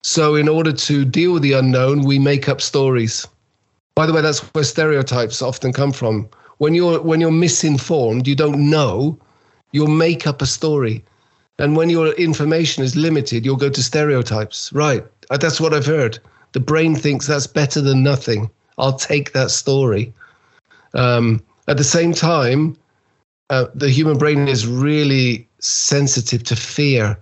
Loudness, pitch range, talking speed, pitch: -16 LUFS, 125-155 Hz, 165 wpm, 140 Hz